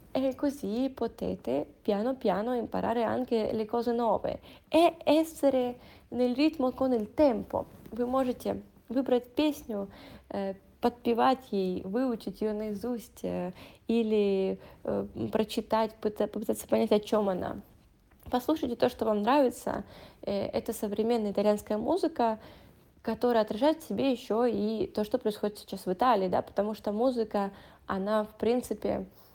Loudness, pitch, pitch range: -30 LUFS, 230 Hz, 210-255 Hz